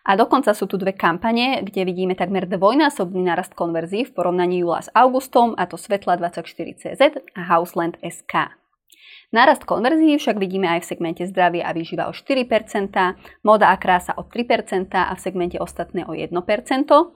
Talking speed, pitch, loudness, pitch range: 165 wpm, 190 Hz, -19 LUFS, 175-225 Hz